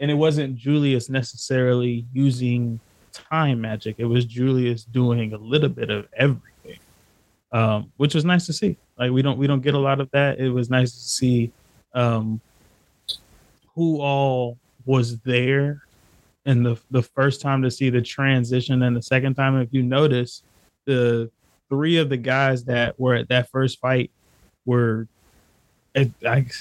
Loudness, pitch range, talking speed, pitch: -22 LUFS, 120-135 Hz, 165 wpm, 125 Hz